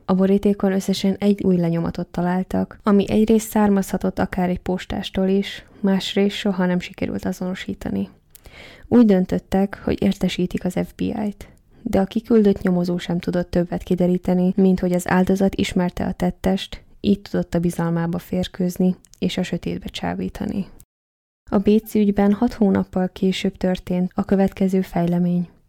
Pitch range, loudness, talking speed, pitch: 180-200 Hz, -21 LUFS, 140 wpm, 190 Hz